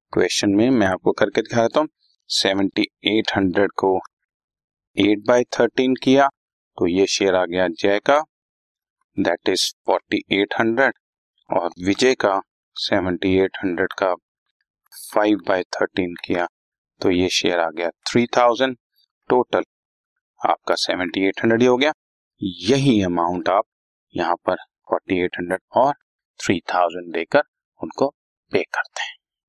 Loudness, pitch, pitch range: -20 LUFS, 105 Hz, 95-130 Hz